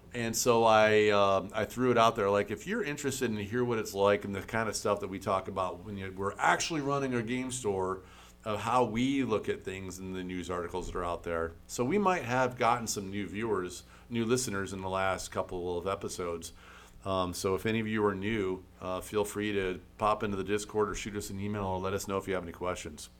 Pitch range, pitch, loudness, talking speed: 95-115 Hz, 100 Hz, -31 LUFS, 250 wpm